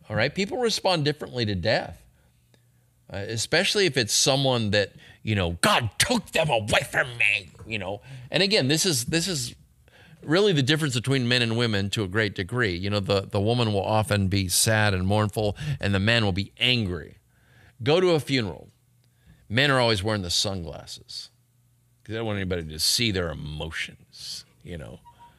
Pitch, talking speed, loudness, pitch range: 115 Hz, 185 wpm, -24 LUFS, 100-135 Hz